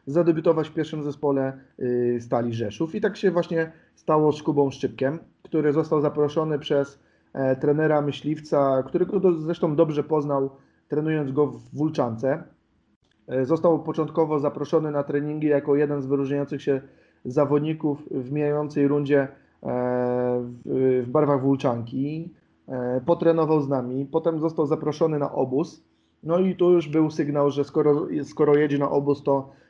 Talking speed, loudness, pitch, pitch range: 135 wpm, -24 LUFS, 145 Hz, 135-155 Hz